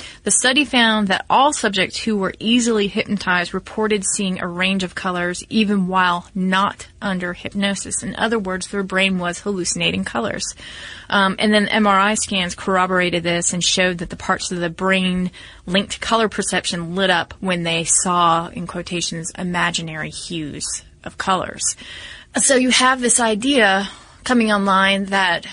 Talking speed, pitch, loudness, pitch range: 160 wpm, 190 Hz, -18 LUFS, 180-210 Hz